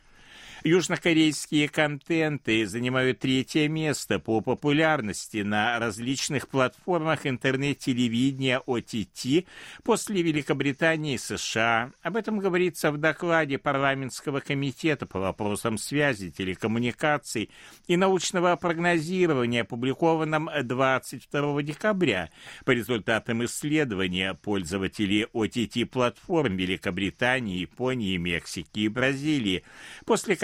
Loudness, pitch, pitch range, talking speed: -26 LUFS, 135 Hz, 115-155 Hz, 85 wpm